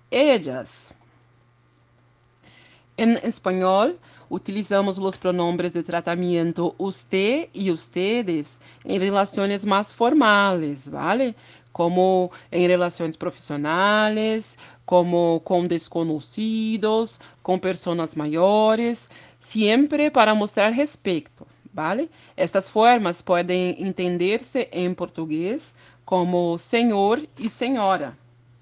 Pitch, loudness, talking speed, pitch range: 185 Hz, -22 LUFS, 90 wpm, 170-215 Hz